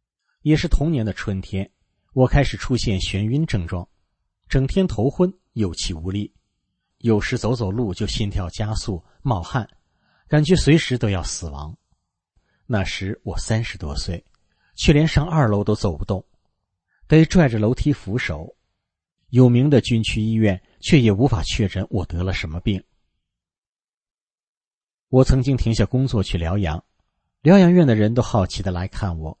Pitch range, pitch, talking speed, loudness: 95-130 Hz, 105 Hz, 220 characters per minute, -20 LUFS